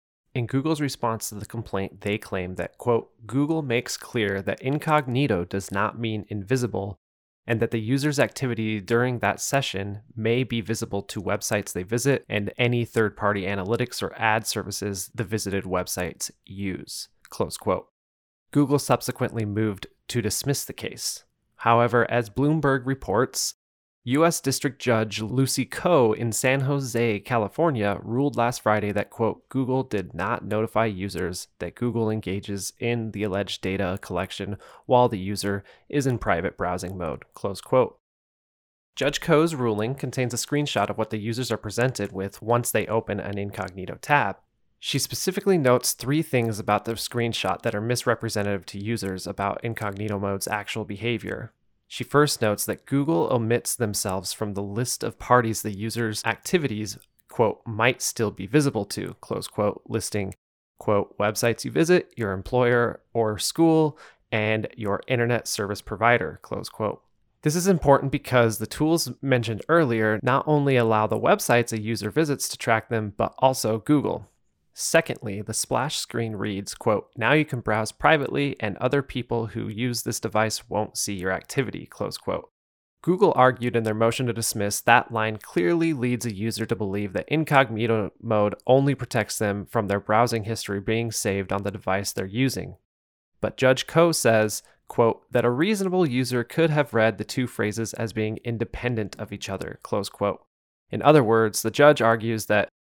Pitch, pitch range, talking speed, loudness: 115 Hz, 100-125 Hz, 165 wpm, -25 LUFS